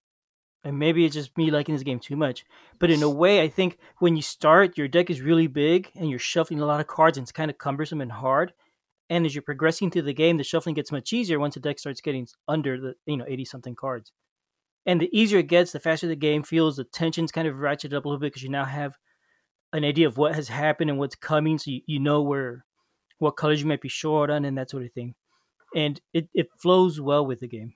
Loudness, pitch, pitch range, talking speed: -24 LUFS, 150 Hz, 140-165 Hz, 255 wpm